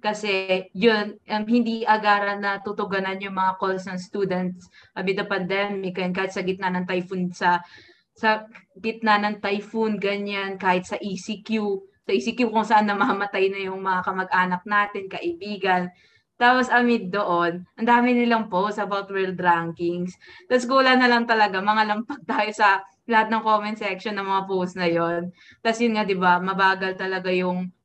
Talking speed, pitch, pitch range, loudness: 165 wpm, 200 Hz, 185-215 Hz, -23 LUFS